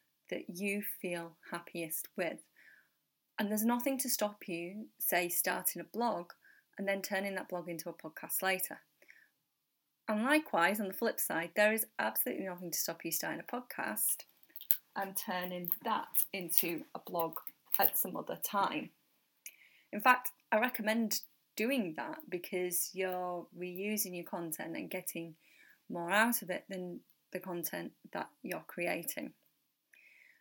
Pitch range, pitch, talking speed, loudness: 175-215 Hz, 190 Hz, 145 wpm, -35 LUFS